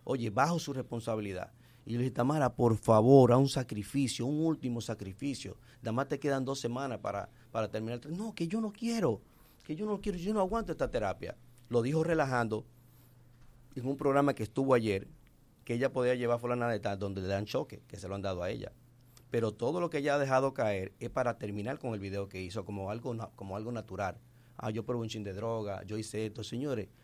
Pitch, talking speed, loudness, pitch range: 120 Hz, 225 wpm, -33 LUFS, 110-135 Hz